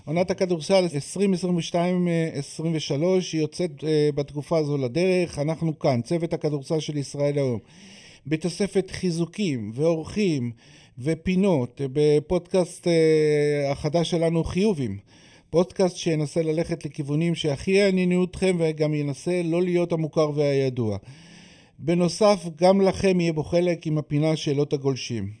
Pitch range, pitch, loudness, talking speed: 145-180 Hz, 160 Hz, -24 LUFS, 110 wpm